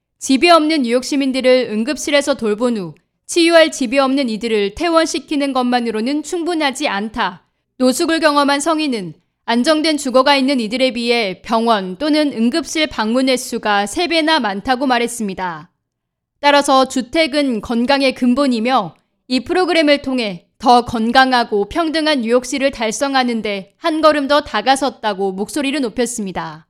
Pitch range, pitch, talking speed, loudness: 230-295 Hz, 260 Hz, 325 characters per minute, -16 LUFS